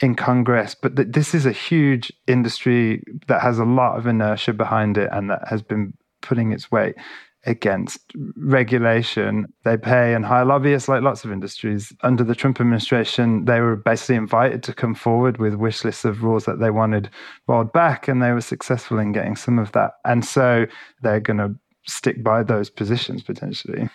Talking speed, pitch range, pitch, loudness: 190 wpm, 110-125 Hz, 115 Hz, -20 LUFS